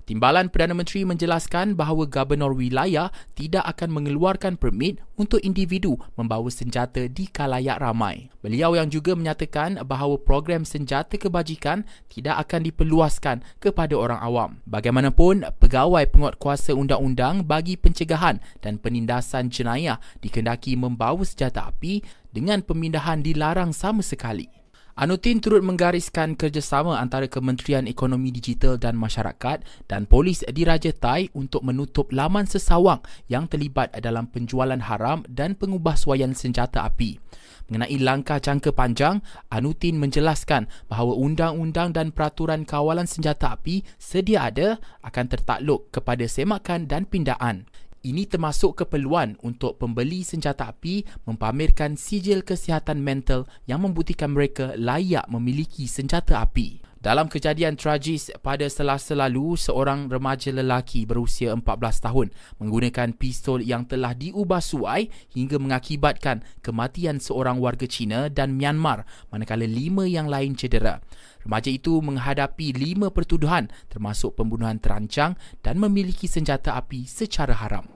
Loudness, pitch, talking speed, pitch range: -24 LUFS, 140 Hz, 125 wpm, 125-165 Hz